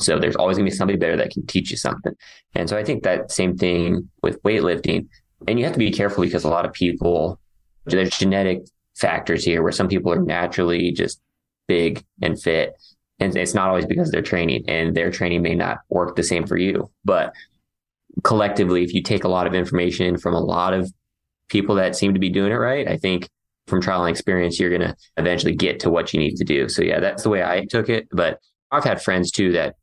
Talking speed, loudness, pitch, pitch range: 230 wpm, -21 LUFS, 90 Hz, 85-95 Hz